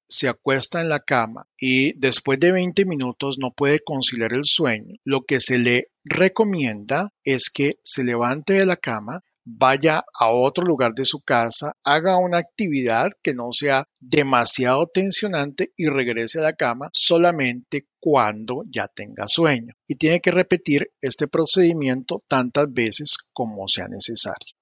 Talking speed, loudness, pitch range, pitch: 155 wpm, -20 LUFS, 125-165 Hz, 140 Hz